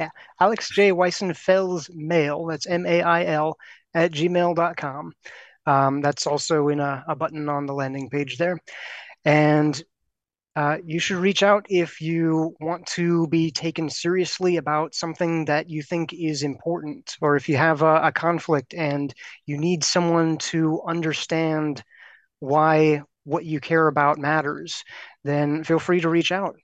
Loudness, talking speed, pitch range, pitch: -22 LUFS, 150 wpm, 150-170 Hz, 160 Hz